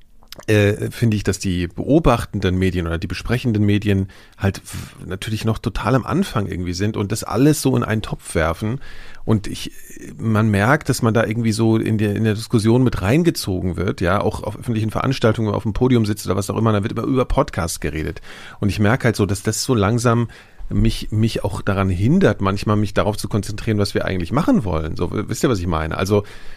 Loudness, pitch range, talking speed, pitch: -19 LUFS, 100-115 Hz, 215 wpm, 105 Hz